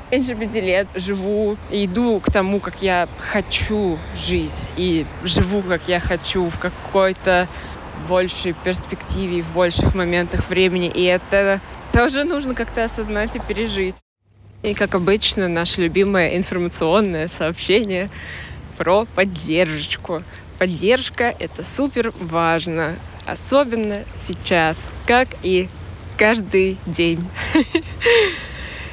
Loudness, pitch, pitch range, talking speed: -19 LUFS, 190 Hz, 175-215 Hz, 105 wpm